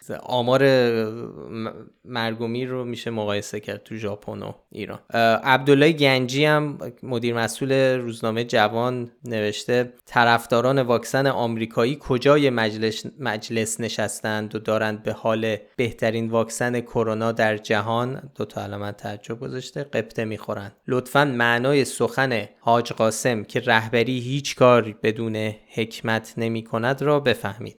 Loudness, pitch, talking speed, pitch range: -22 LUFS, 115 Hz, 120 wpm, 110-125 Hz